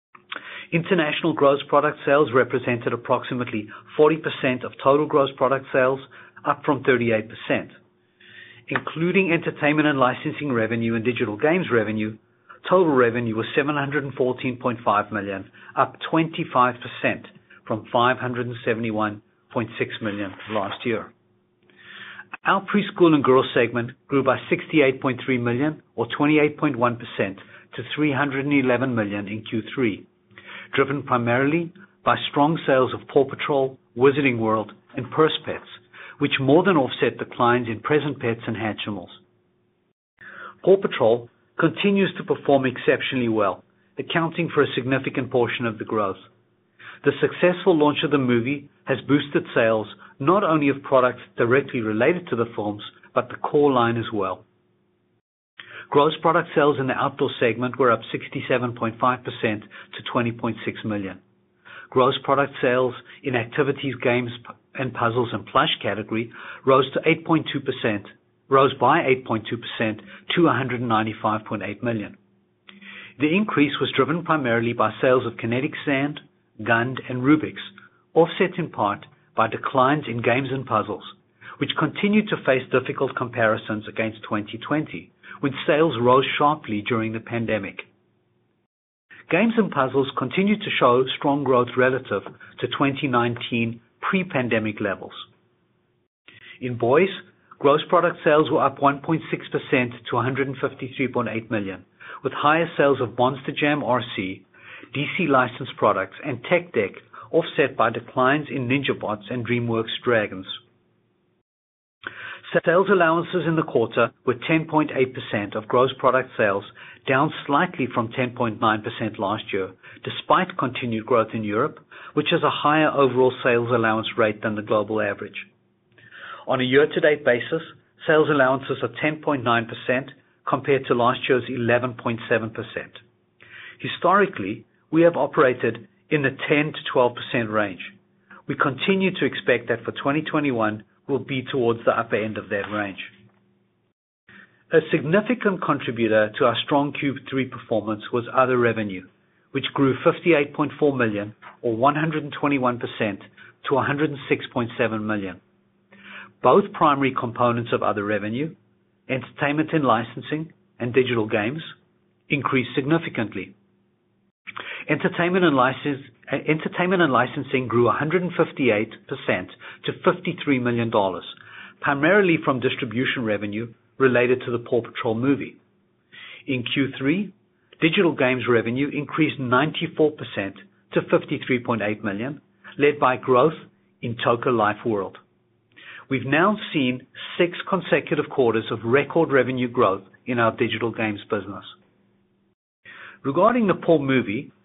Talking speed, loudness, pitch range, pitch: 135 wpm, -22 LUFS, 115-150 Hz, 130 Hz